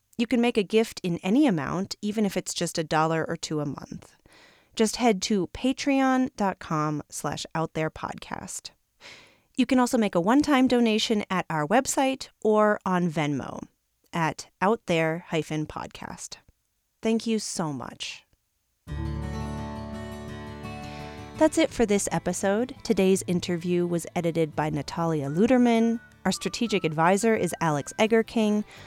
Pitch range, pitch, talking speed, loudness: 160-225 Hz, 185 Hz, 125 wpm, -26 LUFS